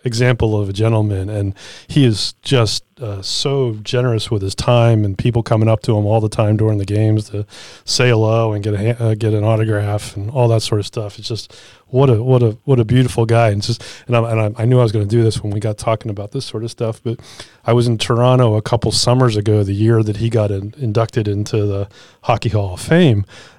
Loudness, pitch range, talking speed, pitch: -16 LUFS, 105-120 Hz, 245 wpm, 115 Hz